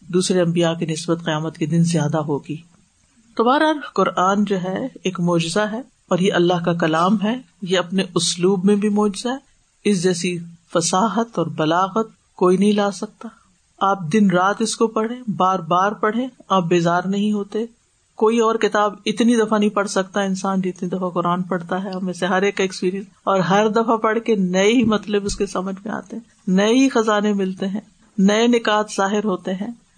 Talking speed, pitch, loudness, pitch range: 185 wpm, 195 Hz, -19 LUFS, 185-220 Hz